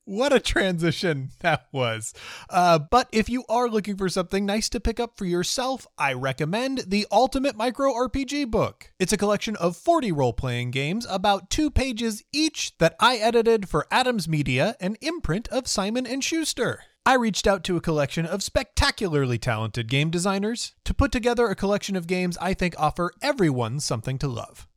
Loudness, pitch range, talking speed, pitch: -24 LUFS, 165-240 Hz, 175 wpm, 200 Hz